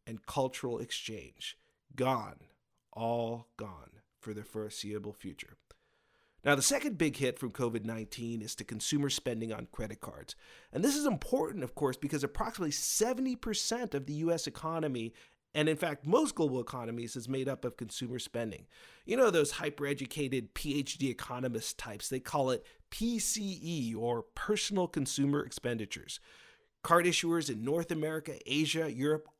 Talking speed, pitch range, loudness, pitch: 150 wpm, 120-160 Hz, -34 LUFS, 140 Hz